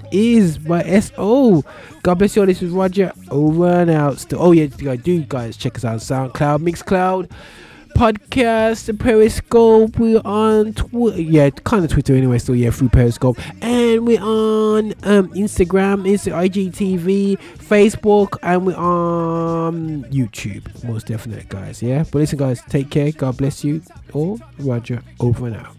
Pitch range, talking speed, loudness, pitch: 135-200 Hz, 155 wpm, -16 LUFS, 170 Hz